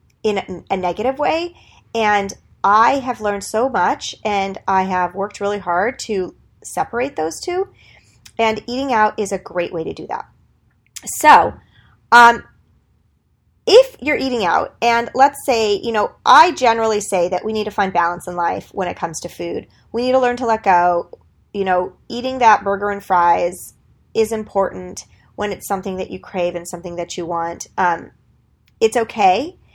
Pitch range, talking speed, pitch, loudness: 180-235 Hz, 175 wpm, 205 Hz, -17 LUFS